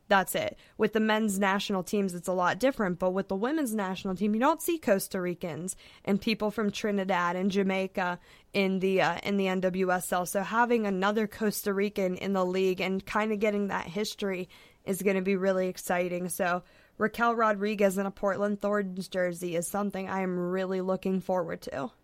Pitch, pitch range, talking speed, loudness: 195 Hz, 185-210 Hz, 190 wpm, -29 LUFS